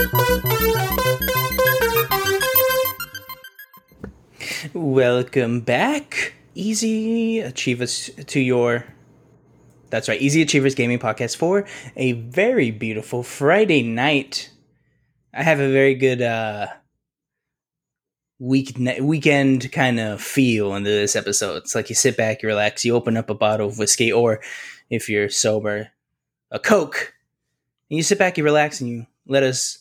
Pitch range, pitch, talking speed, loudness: 115-150 Hz, 130 Hz, 125 wpm, -20 LUFS